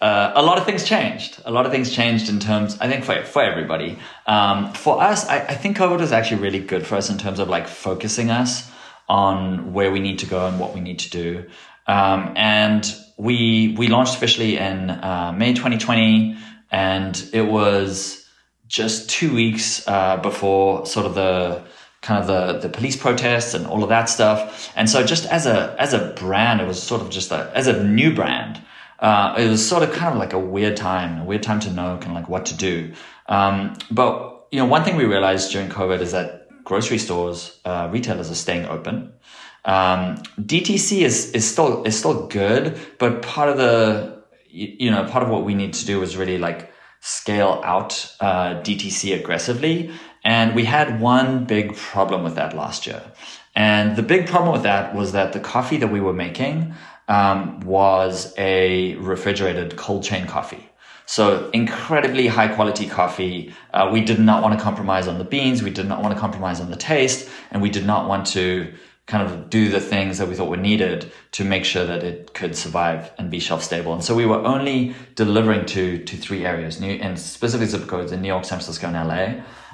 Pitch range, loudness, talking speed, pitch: 95-115 Hz, -20 LUFS, 205 wpm, 100 Hz